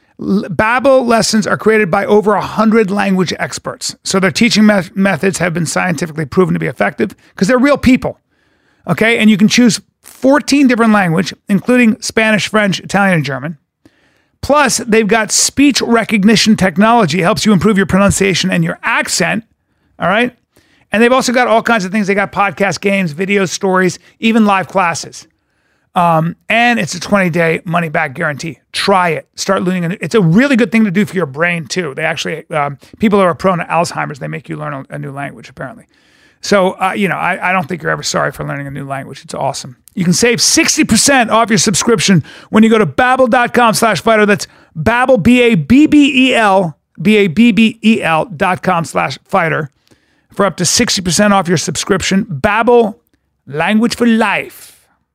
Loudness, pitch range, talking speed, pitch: -12 LUFS, 180-225 Hz, 180 wpm, 200 Hz